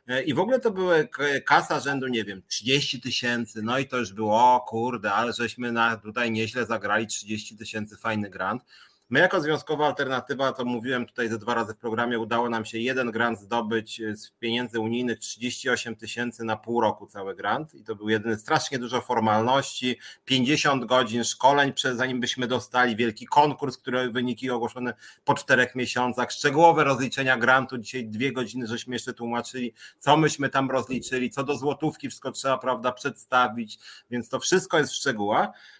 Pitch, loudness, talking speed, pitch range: 125 Hz, -25 LUFS, 175 wpm, 115-130 Hz